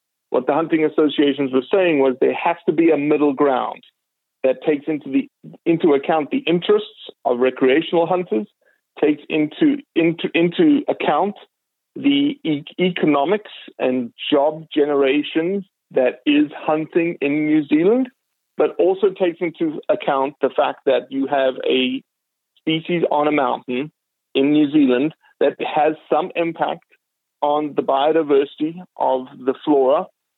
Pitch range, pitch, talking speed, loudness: 140-180 Hz, 155 Hz, 140 wpm, -19 LUFS